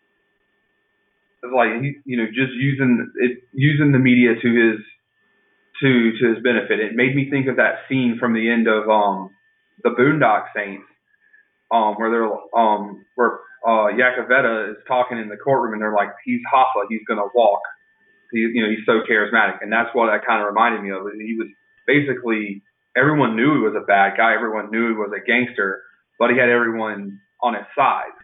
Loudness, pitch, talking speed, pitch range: -19 LUFS, 120 Hz, 185 wpm, 110-130 Hz